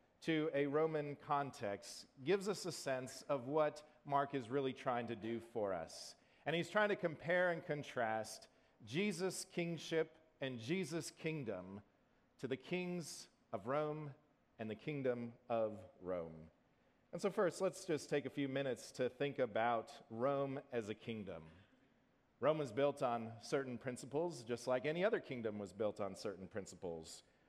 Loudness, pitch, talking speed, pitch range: -42 LUFS, 140 Hz, 155 wpm, 115-160 Hz